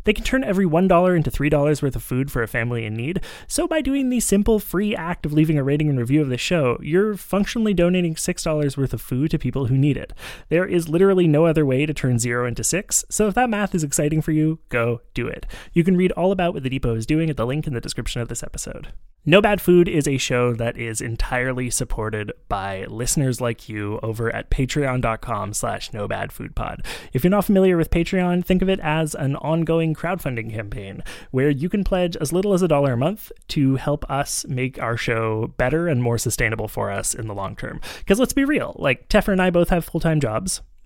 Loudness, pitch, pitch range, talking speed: -21 LUFS, 150 Hz, 120-180 Hz, 235 wpm